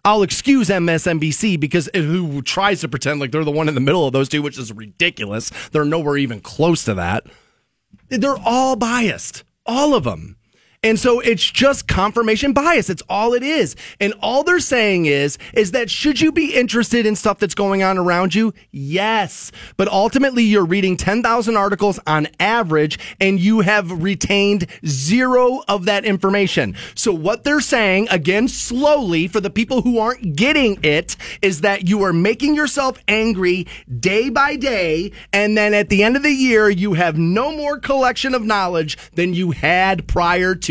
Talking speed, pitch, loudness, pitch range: 180 wpm, 200 Hz, -17 LUFS, 170-235 Hz